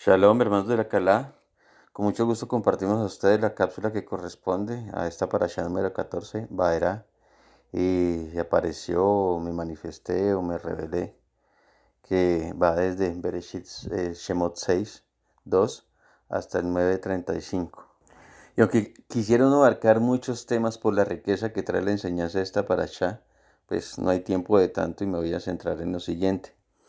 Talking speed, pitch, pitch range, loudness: 155 wpm, 95 Hz, 90-110 Hz, -26 LUFS